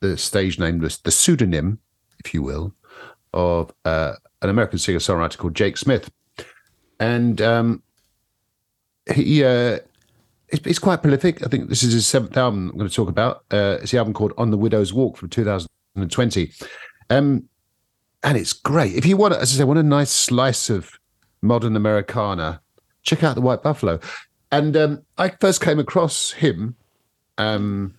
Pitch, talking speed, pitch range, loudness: 110 Hz, 165 wpm, 100-130 Hz, -20 LUFS